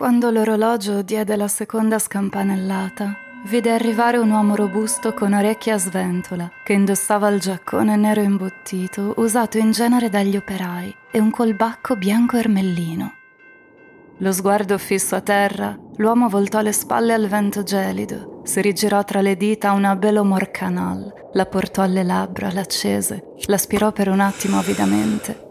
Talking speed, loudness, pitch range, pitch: 145 wpm, -19 LUFS, 195-220 Hz, 205 Hz